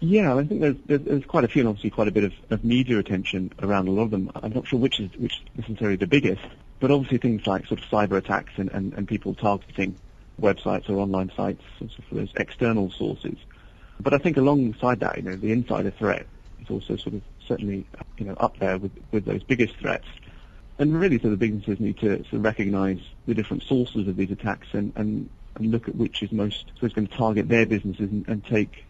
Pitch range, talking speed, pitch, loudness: 100-120 Hz, 235 wpm, 105 Hz, -25 LUFS